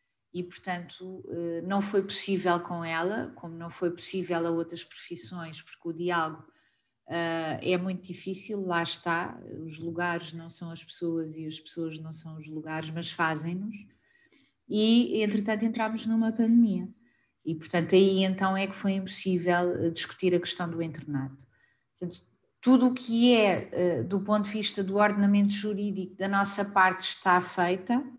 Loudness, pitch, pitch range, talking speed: -28 LUFS, 180 Hz, 170-200 Hz, 155 wpm